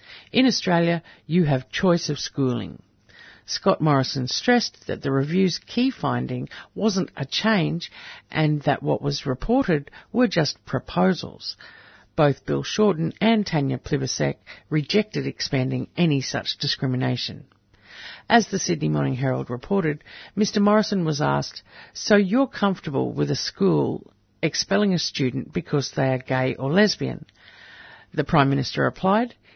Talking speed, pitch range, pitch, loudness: 135 wpm, 130-195 Hz, 150 Hz, -23 LUFS